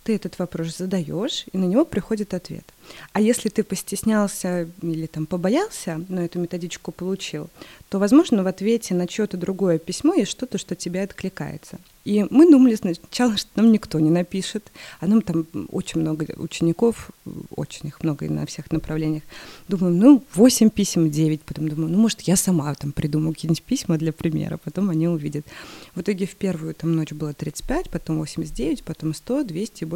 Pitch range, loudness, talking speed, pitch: 160-210 Hz, -22 LUFS, 180 wpm, 180 Hz